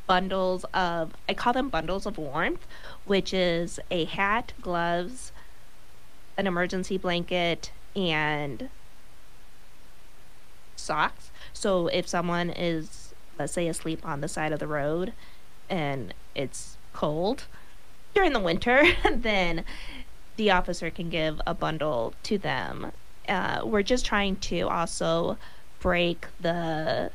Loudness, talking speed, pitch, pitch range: -28 LUFS, 120 wpm, 175 Hz, 165-190 Hz